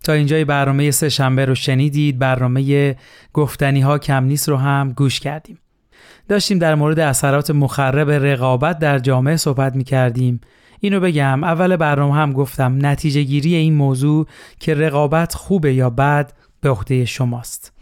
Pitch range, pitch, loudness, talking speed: 135-150 Hz, 140 Hz, -16 LUFS, 150 wpm